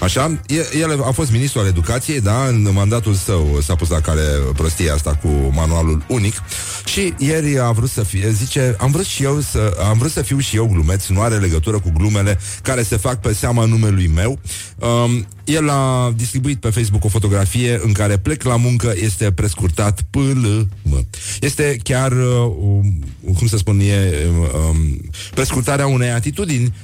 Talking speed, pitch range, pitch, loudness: 175 wpm, 95-125 Hz, 110 Hz, -17 LUFS